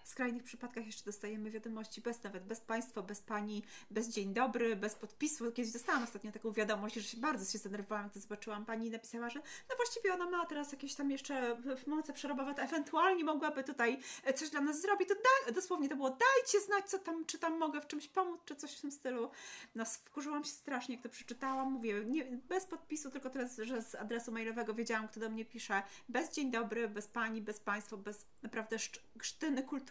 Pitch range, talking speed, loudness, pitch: 225-300 Hz, 210 wpm, -38 LUFS, 245 Hz